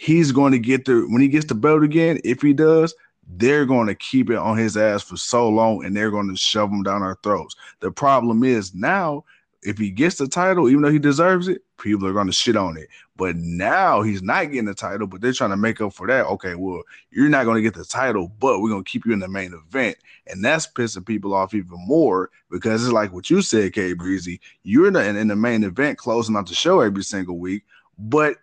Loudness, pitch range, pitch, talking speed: -19 LUFS, 95-140 Hz, 110 Hz, 250 wpm